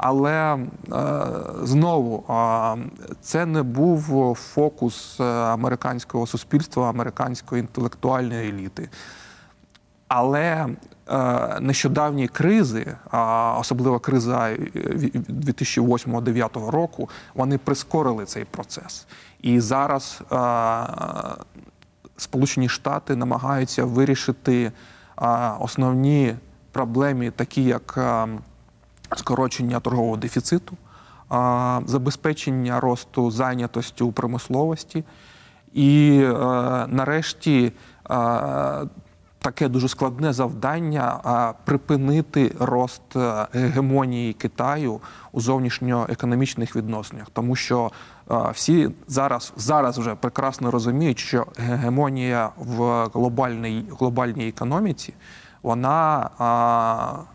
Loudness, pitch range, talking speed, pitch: -22 LUFS, 120-135 Hz, 70 wpm, 125 Hz